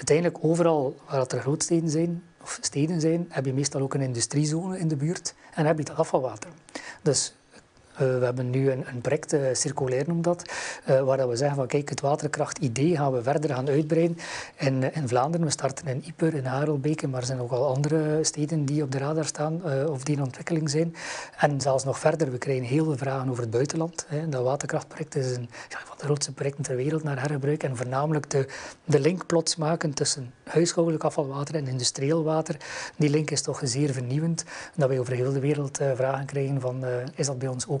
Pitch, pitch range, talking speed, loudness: 145 Hz, 135-160 Hz, 215 wpm, -27 LUFS